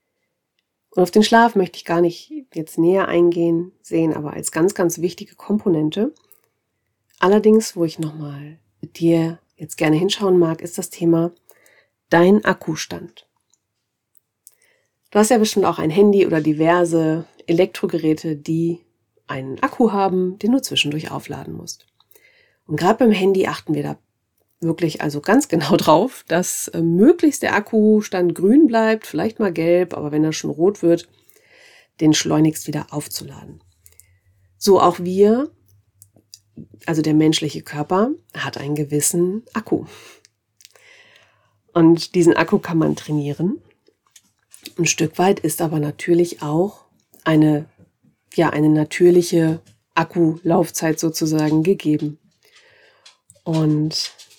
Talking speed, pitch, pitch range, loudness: 130 wpm, 170 Hz, 155-195 Hz, -18 LUFS